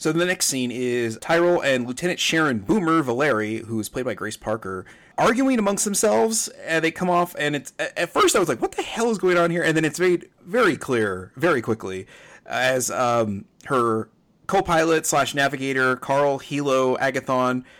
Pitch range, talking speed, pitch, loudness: 125-175 Hz, 185 wpm, 140 Hz, -22 LUFS